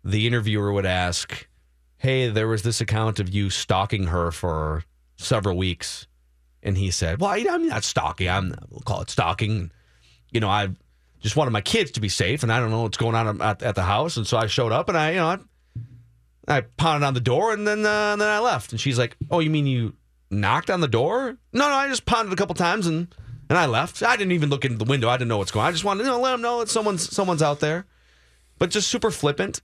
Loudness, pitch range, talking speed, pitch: -23 LUFS, 95-160 Hz, 255 wpm, 115 Hz